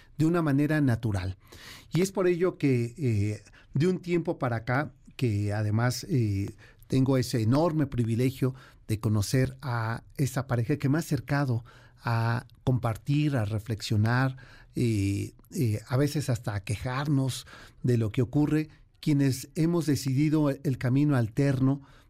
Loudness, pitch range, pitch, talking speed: -28 LUFS, 115-145 Hz, 130 Hz, 140 wpm